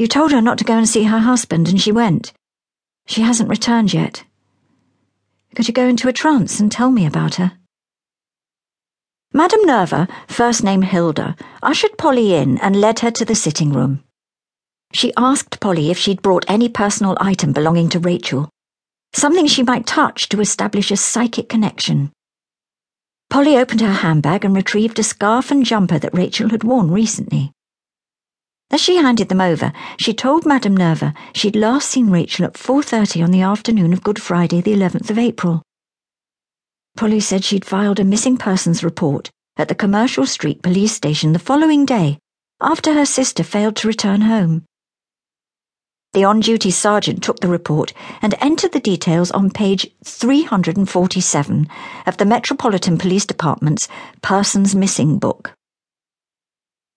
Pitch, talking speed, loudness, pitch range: 205 Hz, 160 wpm, -15 LUFS, 175-235 Hz